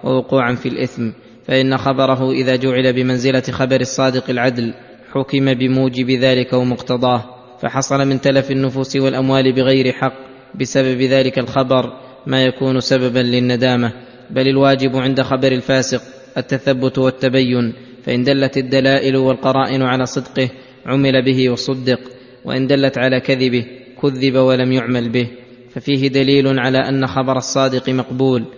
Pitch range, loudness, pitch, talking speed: 125-135 Hz, -16 LUFS, 130 Hz, 125 wpm